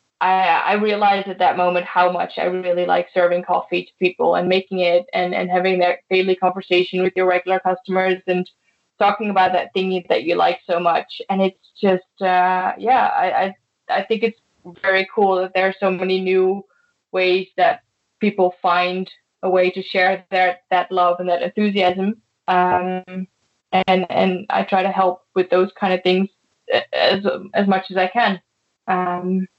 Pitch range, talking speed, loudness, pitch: 180-190 Hz, 180 wpm, -19 LUFS, 185 Hz